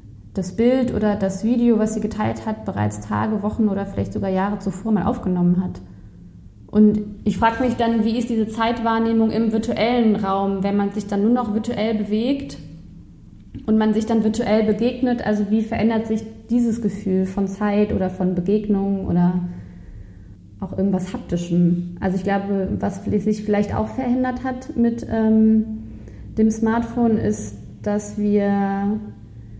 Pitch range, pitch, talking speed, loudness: 185-225 Hz, 210 Hz, 155 wpm, -21 LUFS